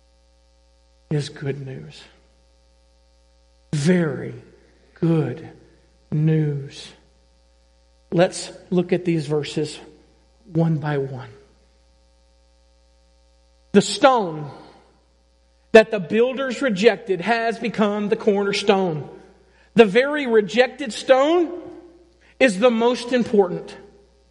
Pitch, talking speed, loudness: 160 Hz, 80 wpm, -20 LUFS